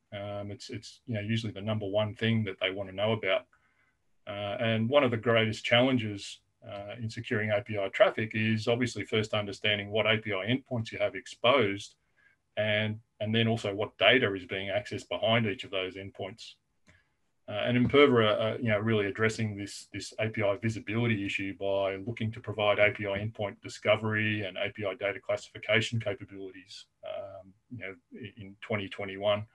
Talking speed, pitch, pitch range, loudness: 165 wpm, 105 Hz, 100-115 Hz, -29 LUFS